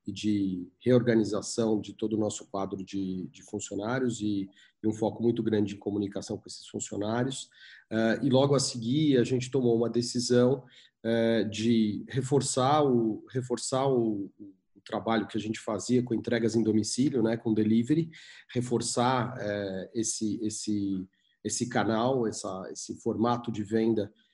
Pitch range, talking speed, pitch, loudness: 105-120 Hz, 155 wpm, 110 Hz, -29 LUFS